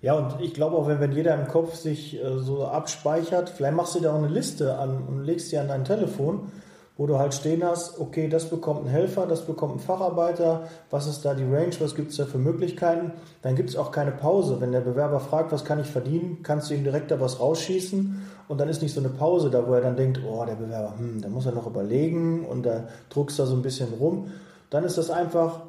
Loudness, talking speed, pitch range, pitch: -26 LUFS, 250 wpm, 135-165 Hz, 150 Hz